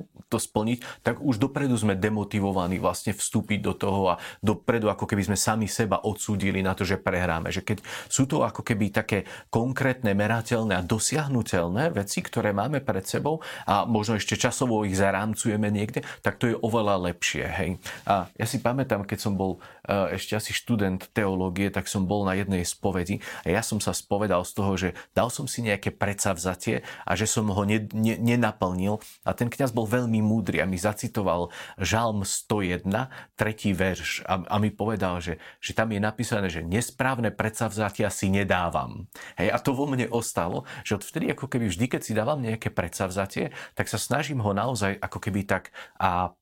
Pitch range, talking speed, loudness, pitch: 95-115 Hz, 185 wpm, -27 LUFS, 105 Hz